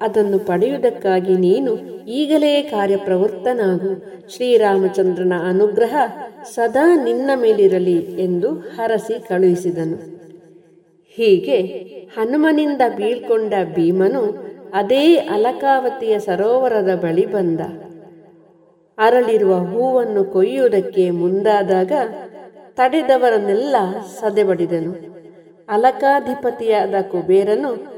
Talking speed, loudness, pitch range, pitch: 65 wpm, -17 LUFS, 185-250 Hz, 205 Hz